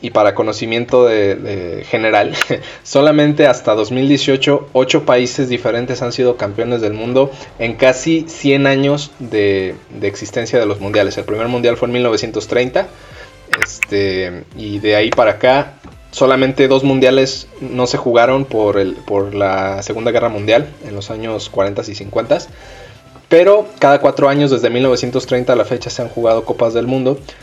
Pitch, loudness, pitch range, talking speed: 125 Hz, -14 LUFS, 110-135 Hz, 160 wpm